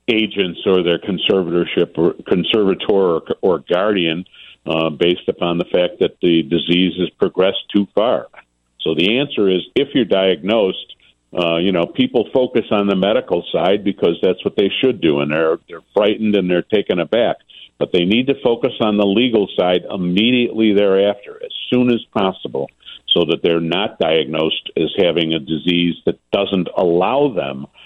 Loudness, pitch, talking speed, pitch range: -17 LUFS, 90 Hz, 170 wpm, 85-105 Hz